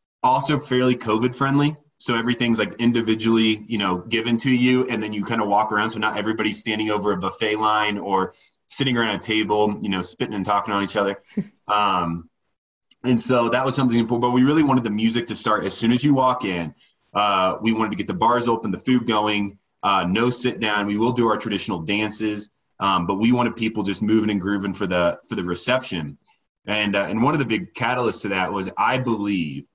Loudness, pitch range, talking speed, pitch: -21 LUFS, 105-120 Hz, 220 wpm, 110 Hz